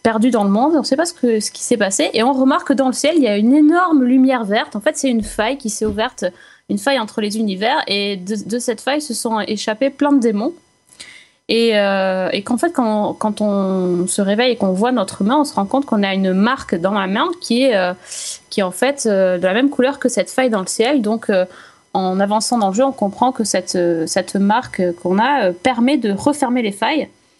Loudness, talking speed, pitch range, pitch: -17 LUFS, 260 wpm, 200-265 Hz, 225 Hz